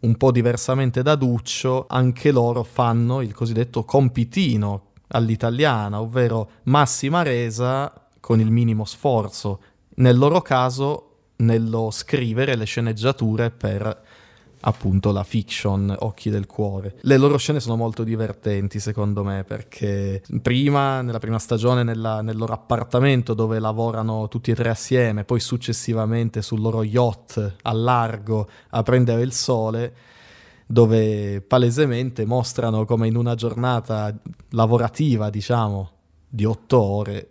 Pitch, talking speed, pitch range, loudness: 115 Hz, 125 wpm, 110-125 Hz, -21 LUFS